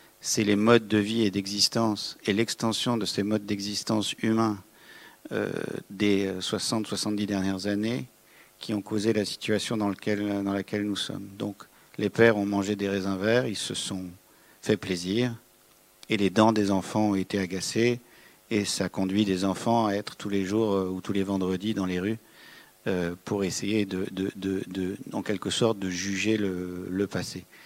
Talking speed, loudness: 180 wpm, -27 LUFS